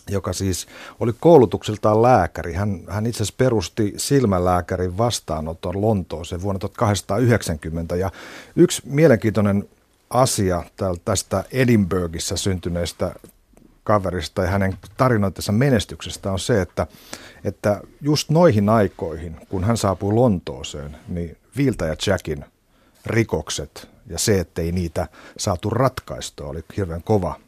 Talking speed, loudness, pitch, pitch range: 115 wpm, -21 LUFS, 100 Hz, 85-110 Hz